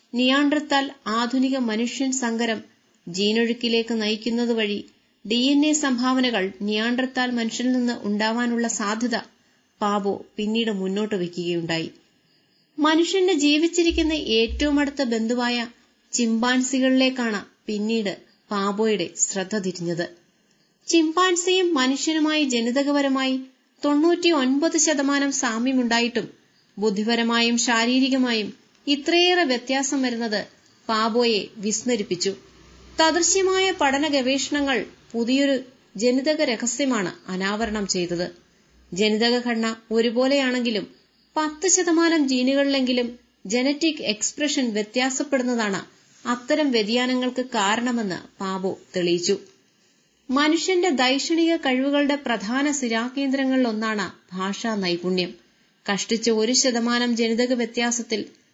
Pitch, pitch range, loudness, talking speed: 240 Hz, 220-275 Hz, -22 LUFS, 80 wpm